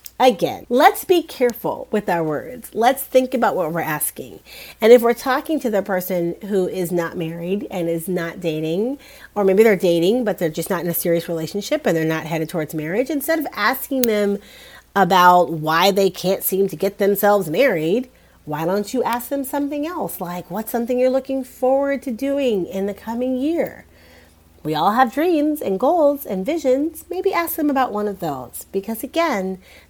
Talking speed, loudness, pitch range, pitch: 190 wpm, -19 LUFS, 175-265 Hz, 205 Hz